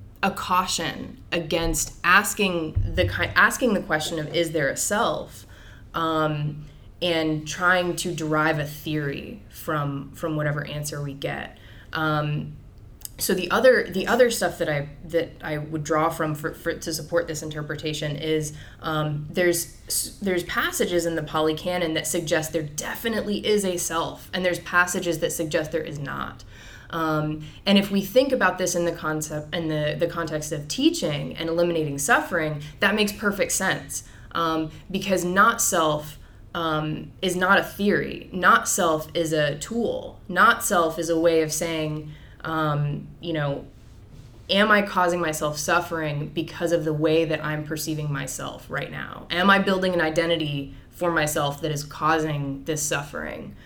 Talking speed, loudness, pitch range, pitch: 160 wpm, -24 LUFS, 150-175 Hz, 160 Hz